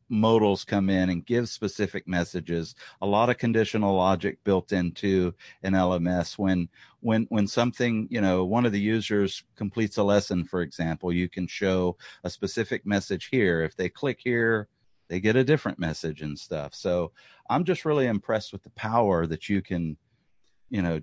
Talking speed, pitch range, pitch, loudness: 175 wpm, 90-110 Hz, 100 Hz, -26 LUFS